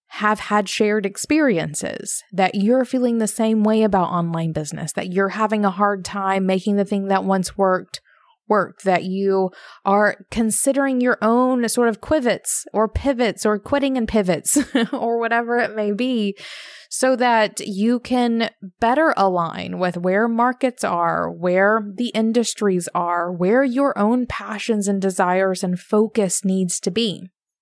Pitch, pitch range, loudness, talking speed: 210 Hz, 190-240 Hz, -20 LUFS, 155 wpm